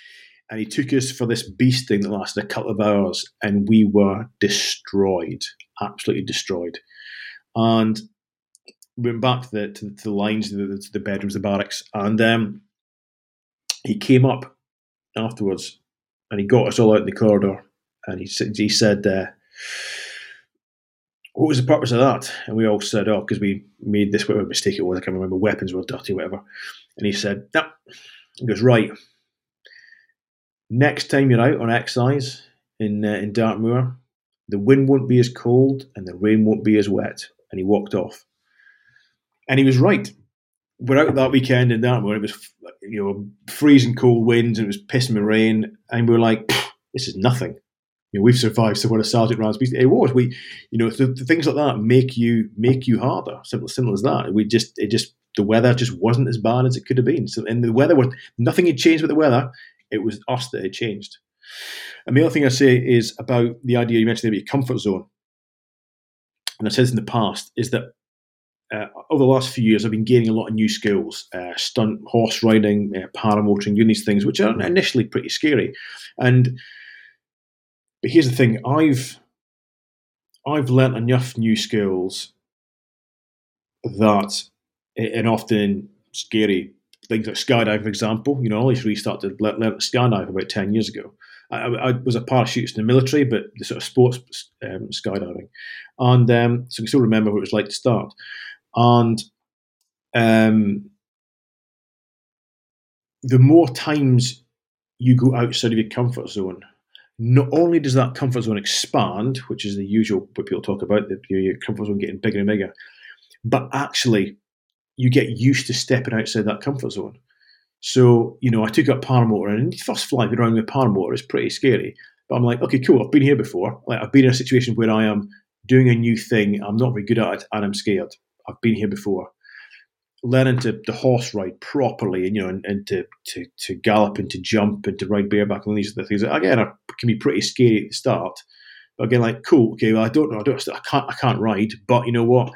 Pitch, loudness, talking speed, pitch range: 115 Hz, -19 LUFS, 200 wpm, 105-130 Hz